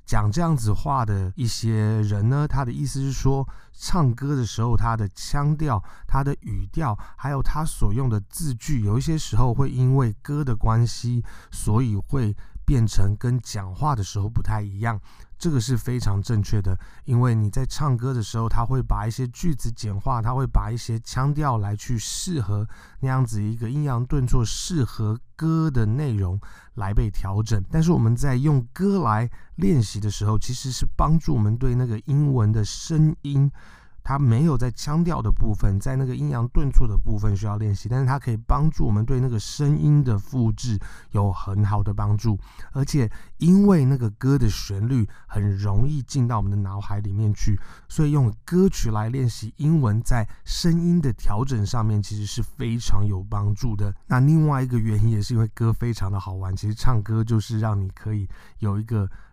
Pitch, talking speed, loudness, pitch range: 115 Hz, 275 characters per minute, -24 LUFS, 105-135 Hz